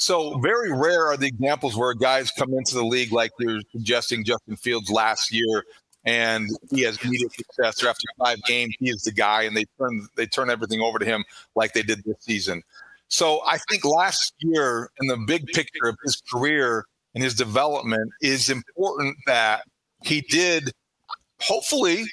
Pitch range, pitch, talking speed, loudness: 110-135 Hz, 120 Hz, 180 wpm, -23 LUFS